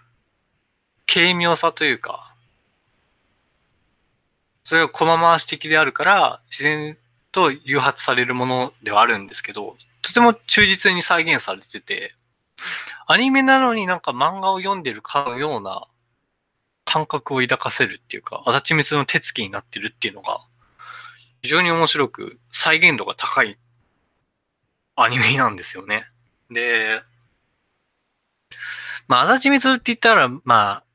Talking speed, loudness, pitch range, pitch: 265 characters per minute, -18 LUFS, 120-185 Hz, 150 Hz